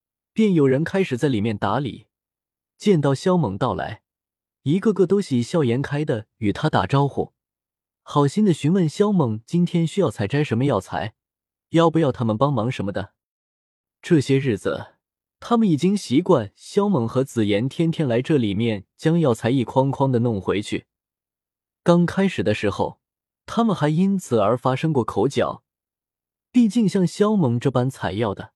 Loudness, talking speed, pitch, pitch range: -21 LUFS, 240 characters per minute, 140 Hz, 115-175 Hz